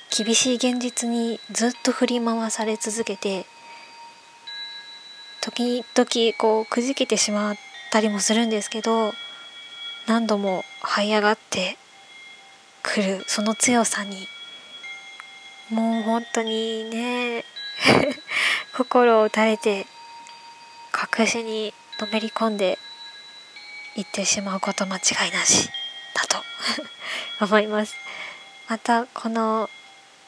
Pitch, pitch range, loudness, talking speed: 230 Hz, 215-245 Hz, -23 LUFS, 195 characters per minute